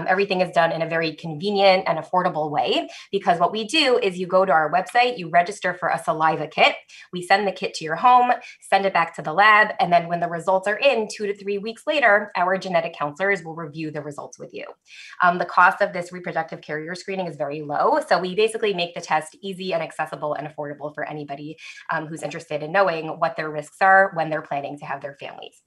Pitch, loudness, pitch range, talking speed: 175 Hz, -21 LUFS, 155-195 Hz, 235 wpm